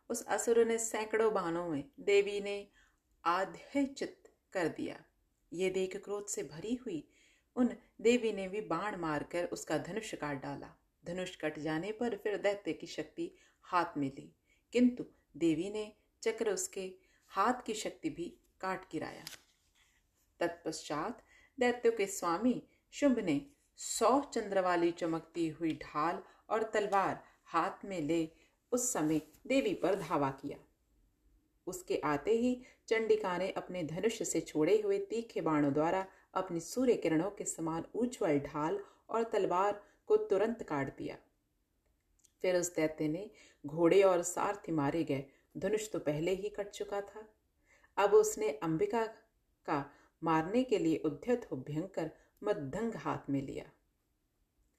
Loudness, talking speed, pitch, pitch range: -35 LUFS, 140 wpm, 195 Hz, 160-230 Hz